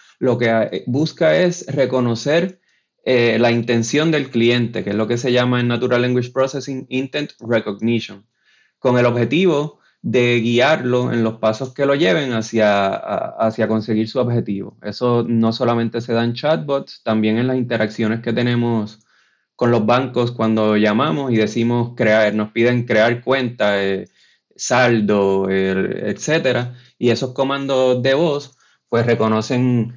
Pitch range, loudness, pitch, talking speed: 110-130 Hz, -18 LUFS, 120 Hz, 150 wpm